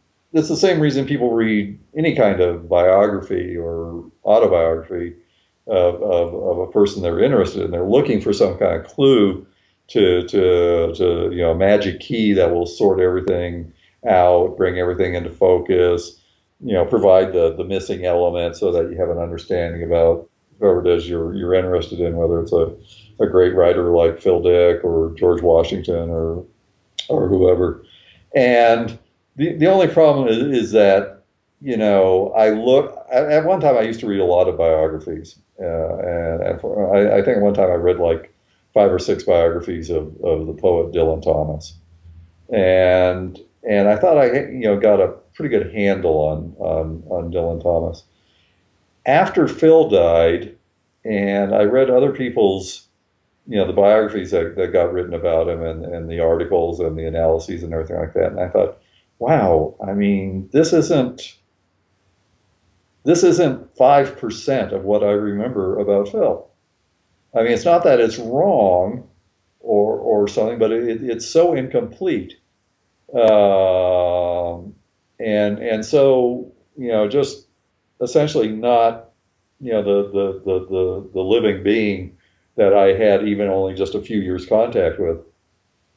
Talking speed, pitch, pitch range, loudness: 165 wpm, 95 Hz, 85-110 Hz, -17 LUFS